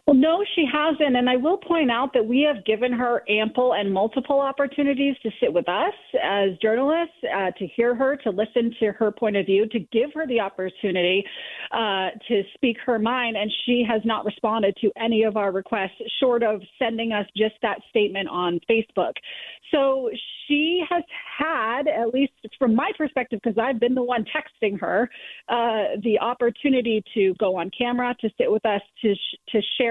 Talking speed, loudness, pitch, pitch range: 190 wpm, -23 LUFS, 230 Hz, 210-265 Hz